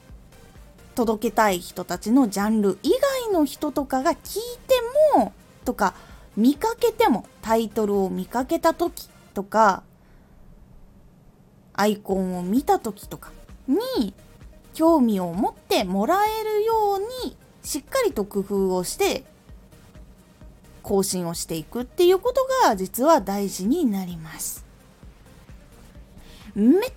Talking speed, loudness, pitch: 230 characters per minute, -23 LUFS, 240 Hz